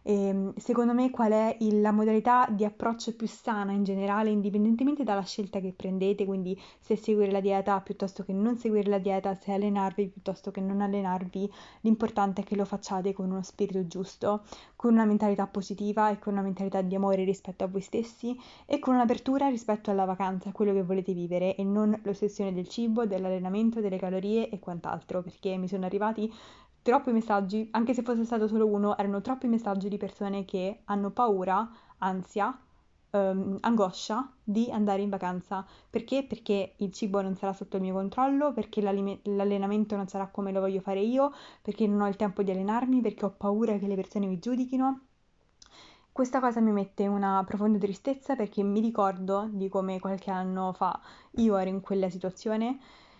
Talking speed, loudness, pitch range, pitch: 180 wpm, -29 LUFS, 195-220 Hz, 205 Hz